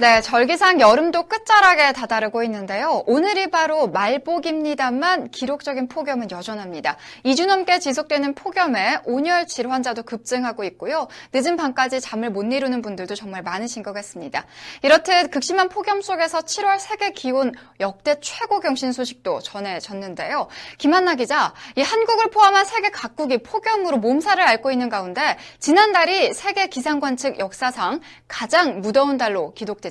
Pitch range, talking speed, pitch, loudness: 230-355 Hz, 355 characters per minute, 275 Hz, -20 LUFS